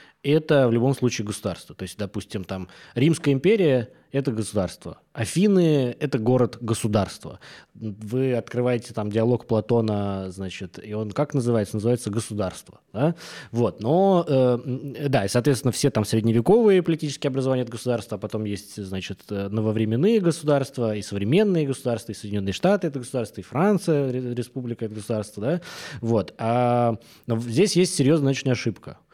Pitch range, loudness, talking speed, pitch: 110-140 Hz, -23 LUFS, 145 wpm, 120 Hz